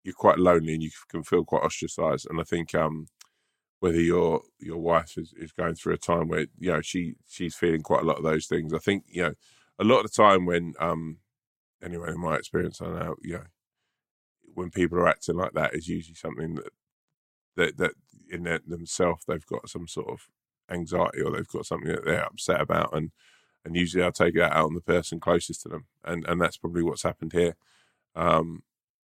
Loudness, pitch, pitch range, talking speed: -27 LUFS, 85 Hz, 80-90 Hz, 215 wpm